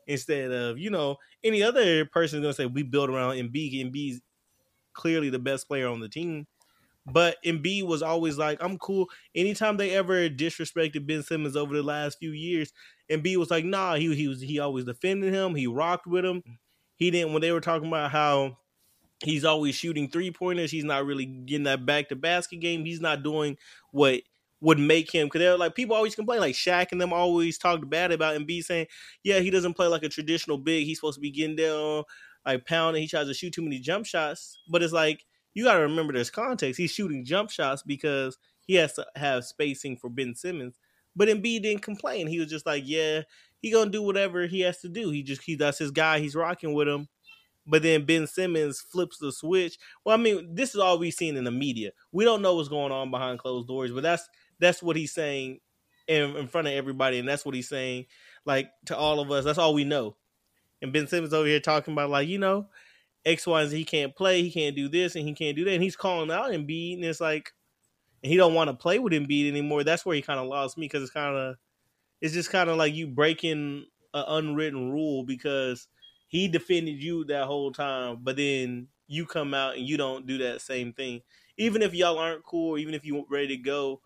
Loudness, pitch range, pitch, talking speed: -27 LUFS, 140-170 Hz, 155 Hz, 230 wpm